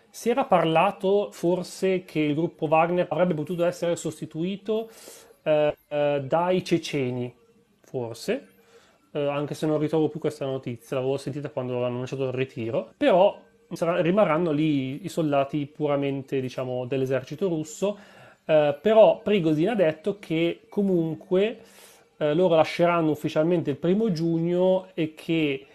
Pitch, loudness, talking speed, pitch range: 160 Hz, -25 LUFS, 135 wpm, 145-180 Hz